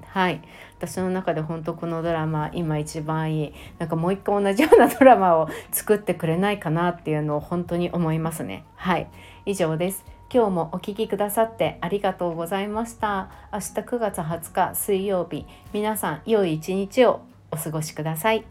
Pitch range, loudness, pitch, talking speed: 160-205 Hz, -23 LUFS, 180 Hz, 350 characters per minute